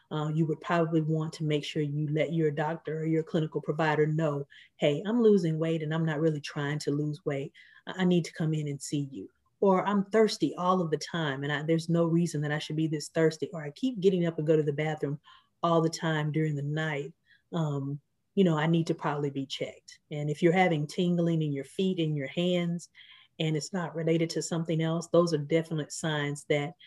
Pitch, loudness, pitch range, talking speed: 160 Hz, -29 LUFS, 150-170 Hz, 230 wpm